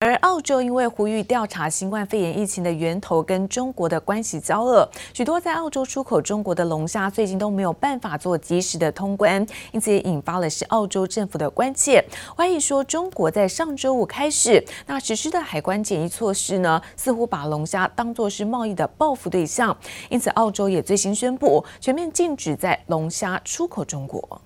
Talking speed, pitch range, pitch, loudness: 300 characters per minute, 180-250 Hz, 210 Hz, -22 LUFS